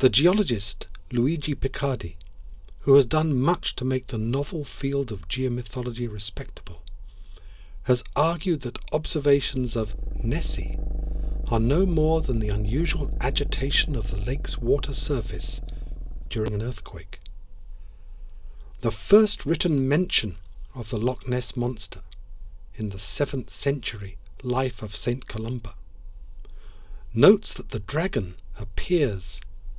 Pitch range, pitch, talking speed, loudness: 95-135 Hz, 110 Hz, 120 wpm, -25 LUFS